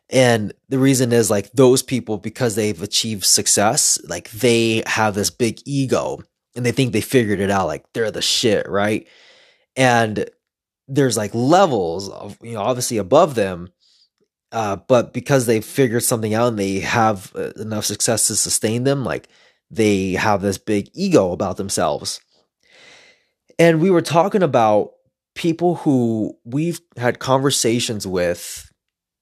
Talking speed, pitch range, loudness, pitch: 150 wpm, 105-140 Hz, -18 LUFS, 120 Hz